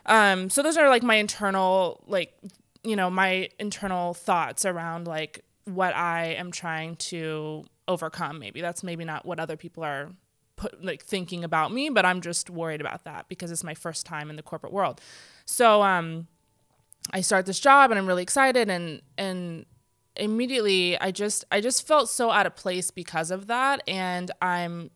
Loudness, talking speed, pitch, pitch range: -25 LUFS, 185 wpm, 180 Hz, 165-200 Hz